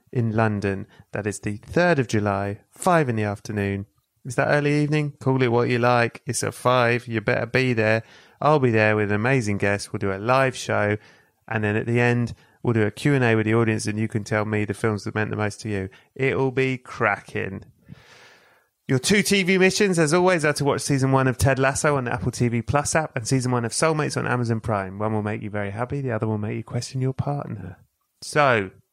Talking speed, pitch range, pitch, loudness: 230 wpm, 105-135 Hz, 120 Hz, -22 LUFS